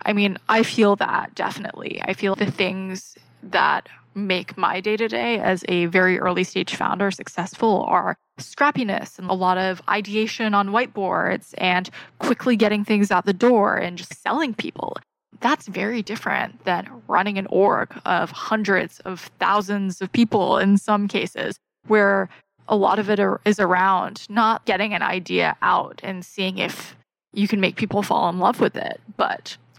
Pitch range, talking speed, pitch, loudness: 185-215 Hz, 165 wpm, 200 Hz, -21 LUFS